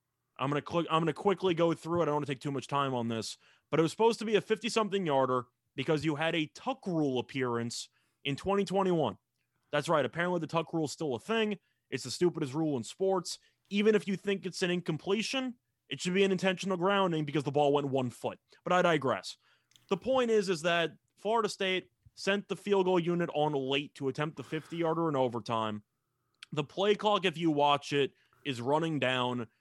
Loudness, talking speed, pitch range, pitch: -31 LUFS, 220 wpm, 135-190 Hz, 160 Hz